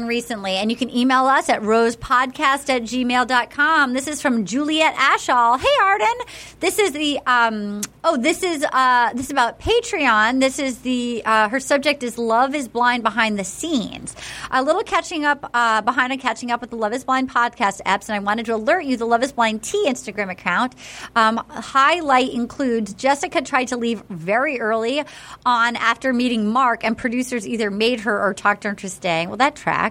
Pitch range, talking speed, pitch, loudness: 225-275 Hz, 195 wpm, 245 Hz, -19 LUFS